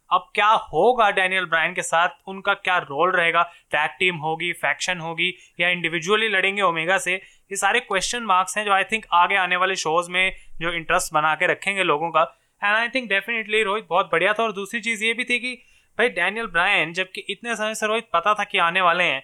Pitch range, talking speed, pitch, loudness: 170-210 Hz, 220 wpm, 185 Hz, -21 LUFS